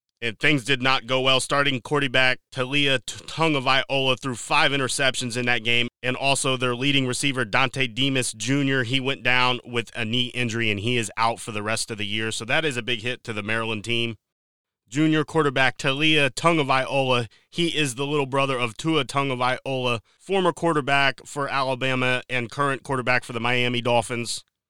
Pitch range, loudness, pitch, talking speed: 120-140 Hz, -23 LUFS, 130 Hz, 195 wpm